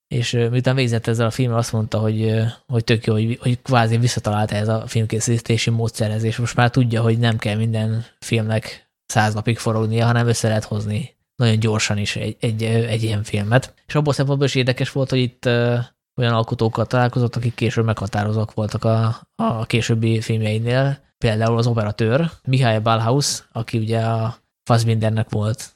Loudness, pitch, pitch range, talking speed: -20 LUFS, 115 Hz, 110-120 Hz, 170 wpm